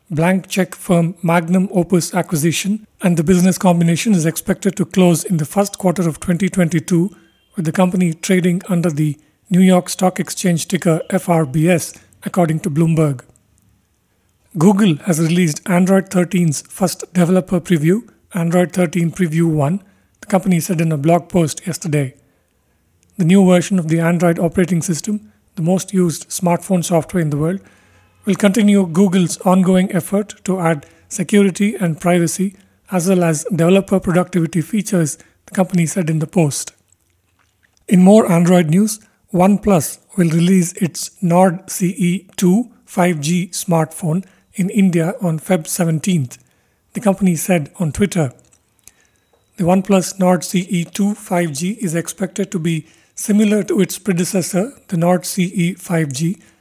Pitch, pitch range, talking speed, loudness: 180 Hz, 165-190 Hz, 140 wpm, -16 LUFS